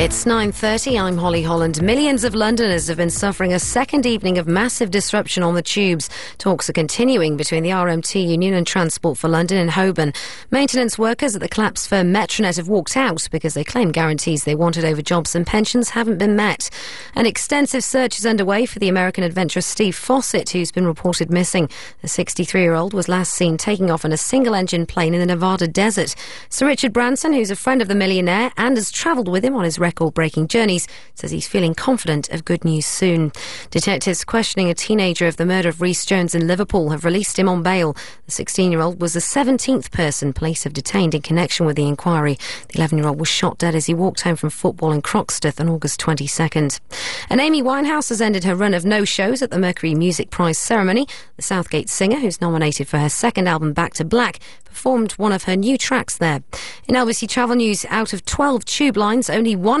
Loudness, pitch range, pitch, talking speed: -18 LUFS, 165-225 Hz, 185 Hz, 210 wpm